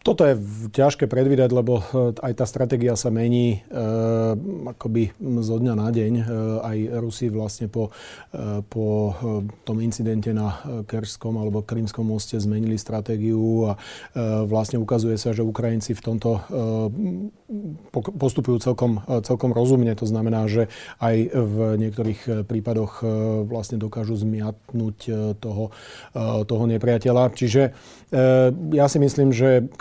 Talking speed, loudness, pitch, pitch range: 135 wpm, -23 LUFS, 115 Hz, 110-125 Hz